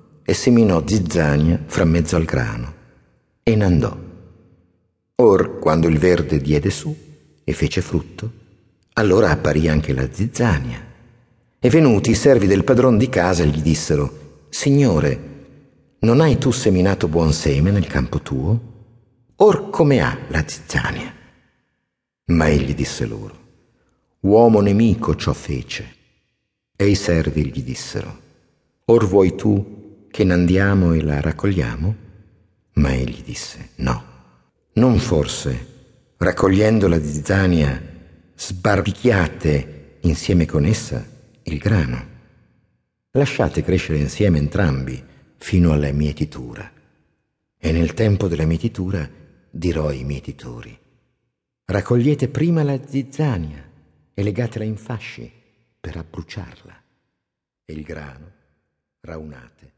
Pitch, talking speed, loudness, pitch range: 90 Hz, 115 wpm, -18 LUFS, 75-110 Hz